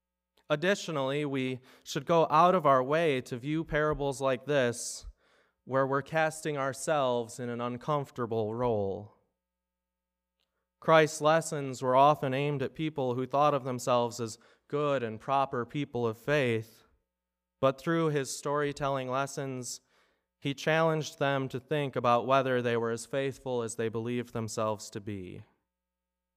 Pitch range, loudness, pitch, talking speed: 115-145 Hz, -30 LUFS, 130 Hz, 140 wpm